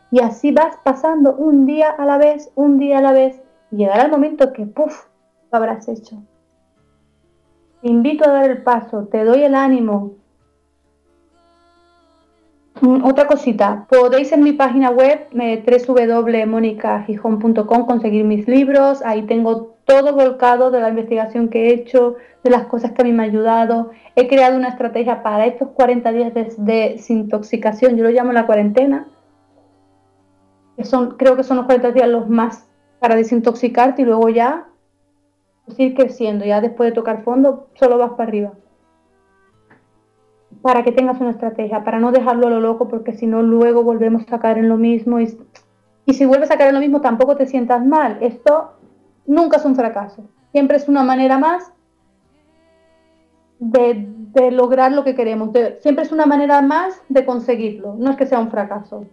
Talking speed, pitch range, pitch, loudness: 170 wpm, 220-265 Hz, 240 Hz, -15 LUFS